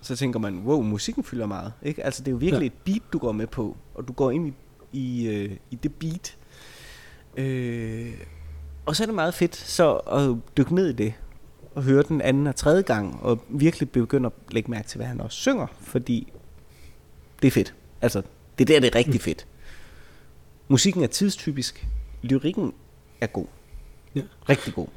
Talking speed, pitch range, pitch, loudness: 190 wpm, 95-145 Hz, 125 Hz, -25 LUFS